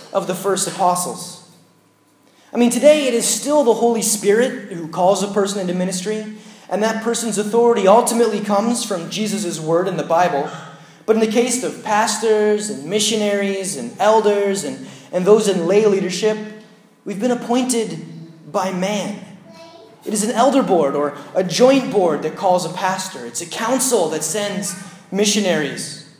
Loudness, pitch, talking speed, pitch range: -18 LUFS, 205 Hz, 165 wpm, 185-220 Hz